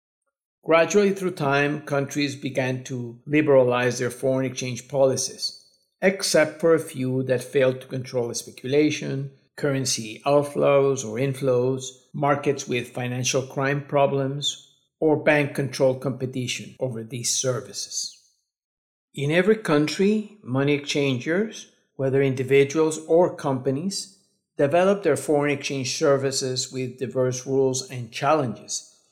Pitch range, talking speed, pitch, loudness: 130-150 Hz, 115 wpm, 135 Hz, -23 LUFS